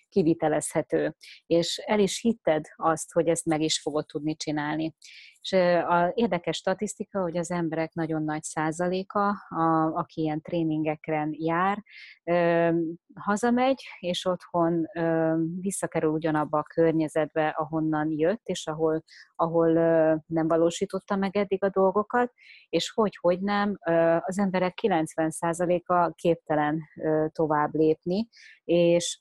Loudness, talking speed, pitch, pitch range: -26 LUFS, 120 wpm, 165 Hz, 160-185 Hz